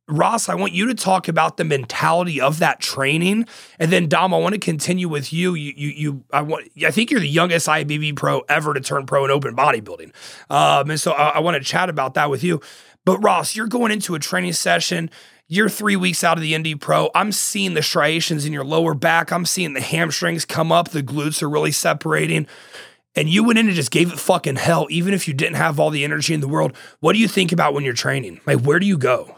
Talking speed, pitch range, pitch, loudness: 245 wpm, 150-185 Hz, 165 Hz, -18 LUFS